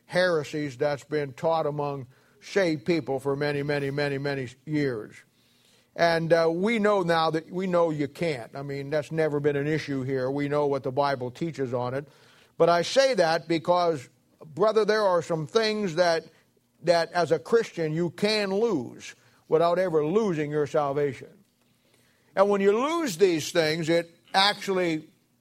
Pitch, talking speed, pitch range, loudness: 160 Hz, 165 wpm, 145-180 Hz, -26 LUFS